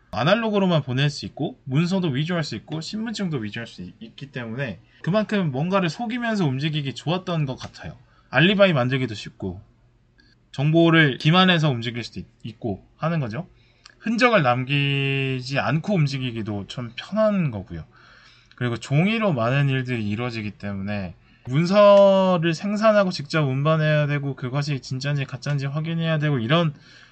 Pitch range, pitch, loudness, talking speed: 120-165 Hz, 140 Hz, -22 LUFS, 345 characters per minute